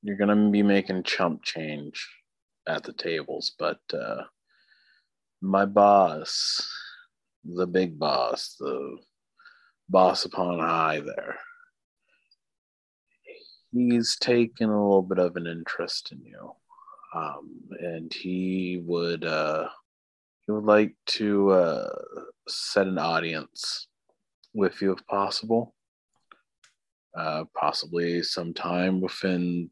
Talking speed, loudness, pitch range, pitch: 105 wpm, -26 LUFS, 85-110 Hz, 95 Hz